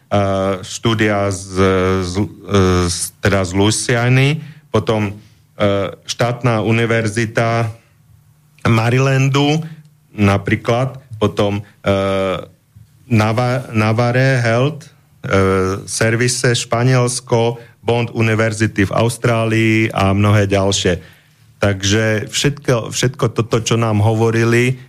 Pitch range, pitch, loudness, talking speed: 100-125 Hz, 115 Hz, -16 LUFS, 85 wpm